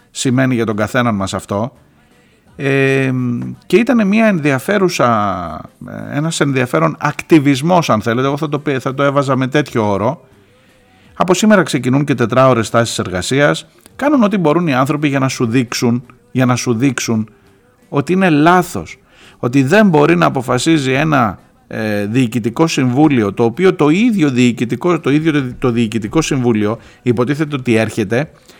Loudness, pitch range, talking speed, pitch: -14 LUFS, 115-150 Hz, 145 wpm, 130 Hz